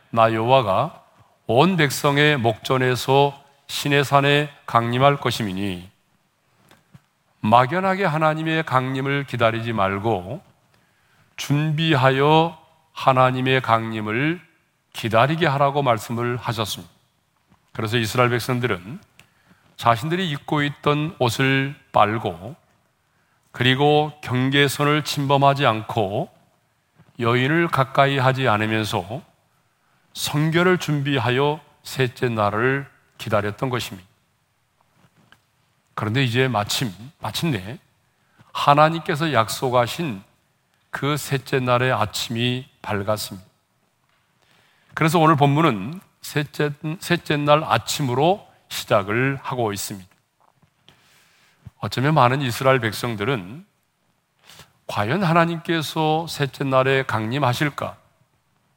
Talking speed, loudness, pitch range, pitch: 225 characters per minute, -20 LUFS, 115-150 Hz, 135 Hz